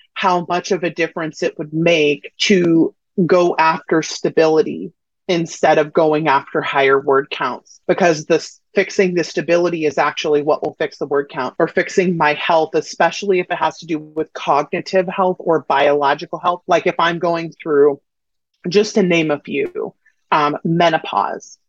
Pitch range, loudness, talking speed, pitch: 150-180 Hz, -17 LUFS, 165 wpm, 165 Hz